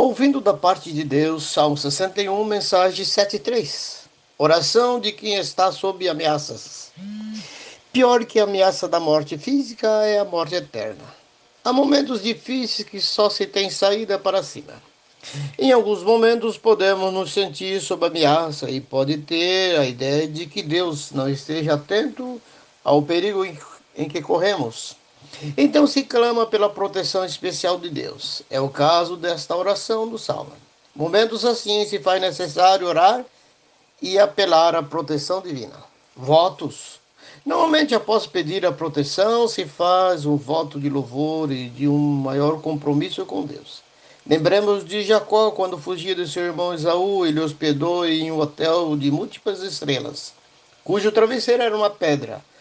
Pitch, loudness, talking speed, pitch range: 185 Hz, -20 LUFS, 145 wpm, 155-210 Hz